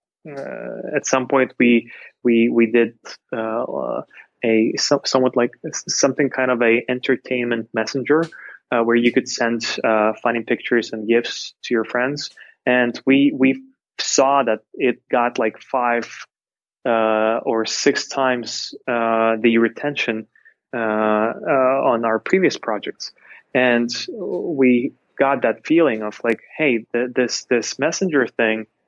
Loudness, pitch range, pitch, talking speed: -19 LUFS, 115-130 Hz, 120 Hz, 135 wpm